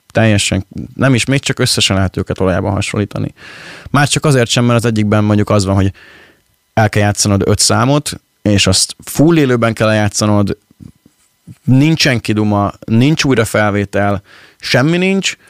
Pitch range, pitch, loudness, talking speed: 100-135 Hz, 110 Hz, -13 LUFS, 150 wpm